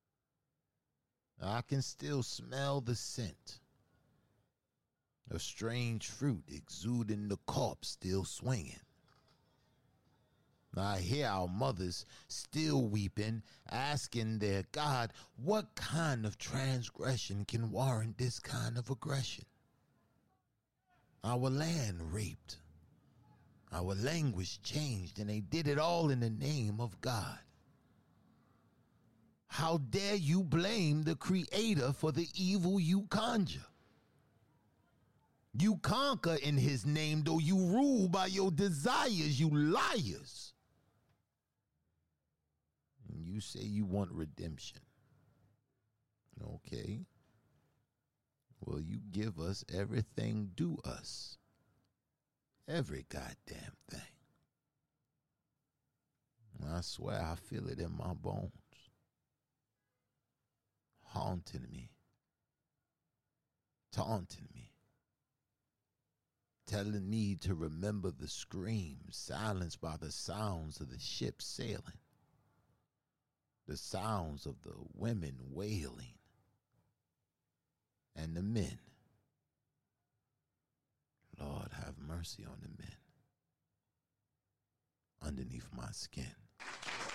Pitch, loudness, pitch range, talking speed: 120 Hz, -38 LUFS, 100-145 Hz, 95 wpm